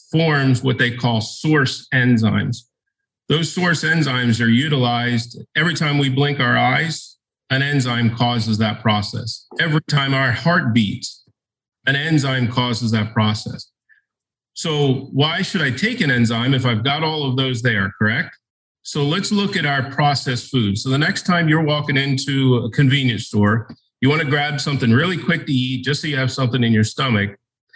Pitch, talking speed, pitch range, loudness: 130 Hz, 175 wpm, 120-150 Hz, -18 LUFS